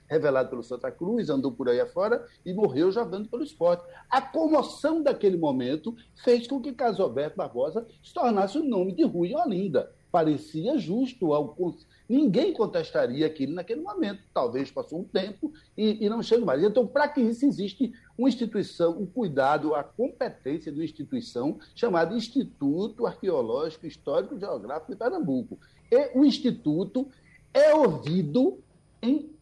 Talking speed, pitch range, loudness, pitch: 155 wpm, 175-280 Hz, -27 LUFS, 235 Hz